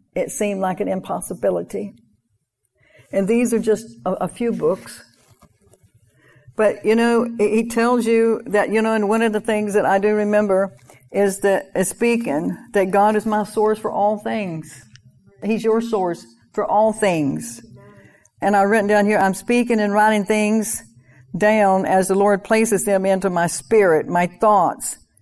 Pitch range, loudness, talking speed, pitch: 175-220 Hz, -19 LUFS, 165 wpm, 205 Hz